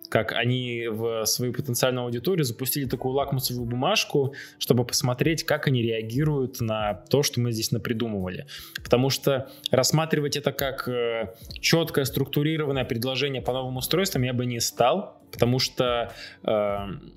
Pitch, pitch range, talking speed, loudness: 130 Hz, 120-140 Hz, 135 wpm, -25 LUFS